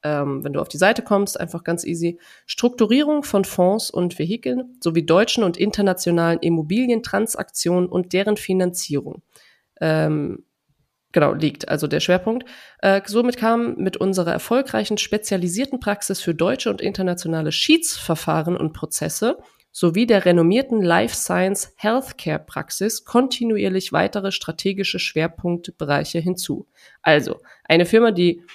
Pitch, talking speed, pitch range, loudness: 185 Hz, 125 wpm, 170-215 Hz, -20 LUFS